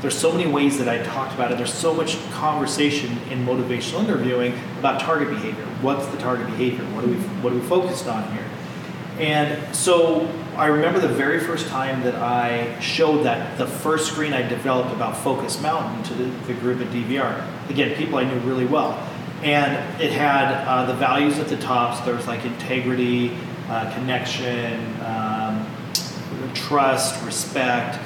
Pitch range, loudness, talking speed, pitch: 125-155 Hz, -22 LUFS, 175 wpm, 130 Hz